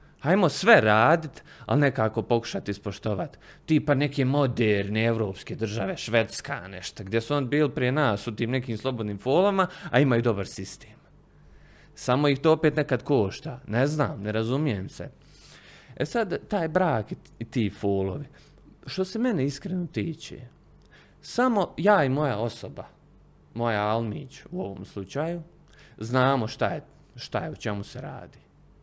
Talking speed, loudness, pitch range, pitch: 150 wpm, -26 LUFS, 110-150 Hz, 125 Hz